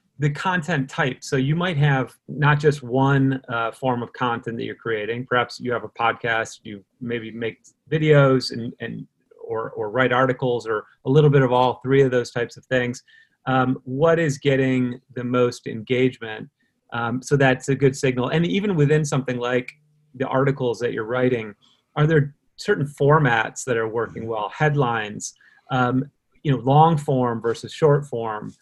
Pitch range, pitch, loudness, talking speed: 120-145 Hz, 130 Hz, -21 LUFS, 175 wpm